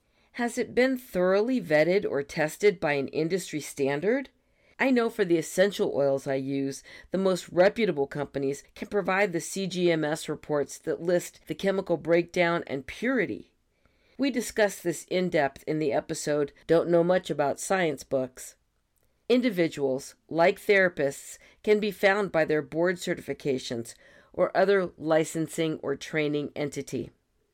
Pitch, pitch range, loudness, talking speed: 165 Hz, 145-195 Hz, -27 LUFS, 140 wpm